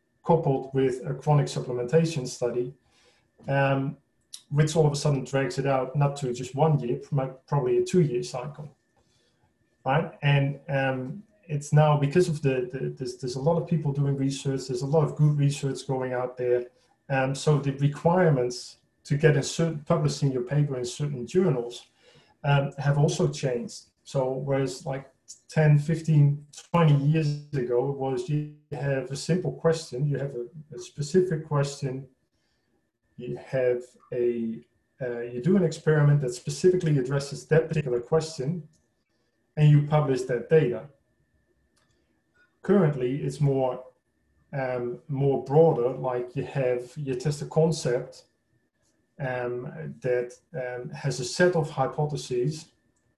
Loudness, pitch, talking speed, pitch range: -26 LUFS, 140 Hz, 145 wpm, 125-155 Hz